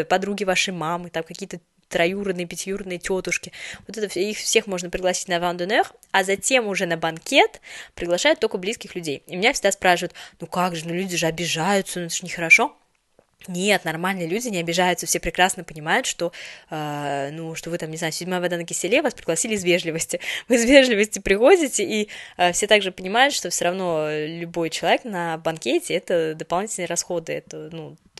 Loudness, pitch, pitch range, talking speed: -22 LUFS, 180 Hz, 170-195 Hz, 185 wpm